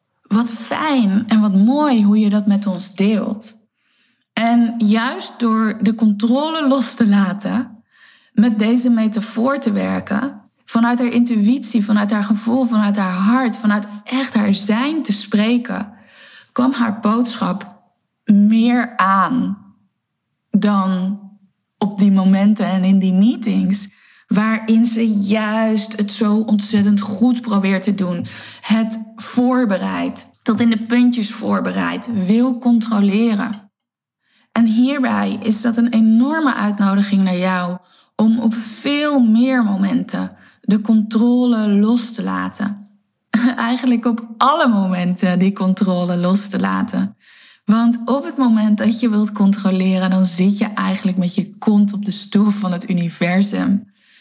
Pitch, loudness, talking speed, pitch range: 215 Hz, -16 LUFS, 135 wpm, 200-235 Hz